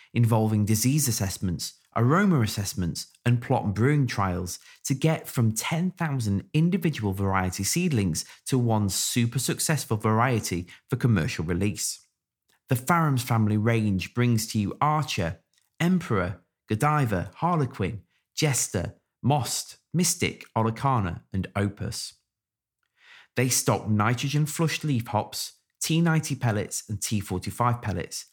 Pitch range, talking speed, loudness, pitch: 100-140 Hz, 110 wpm, -26 LUFS, 115 Hz